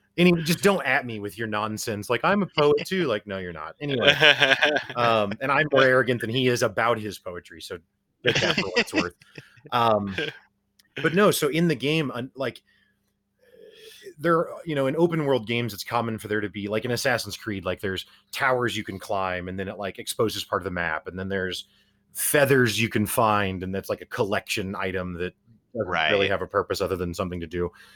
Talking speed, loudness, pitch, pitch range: 215 wpm, -24 LUFS, 115 Hz, 100-140 Hz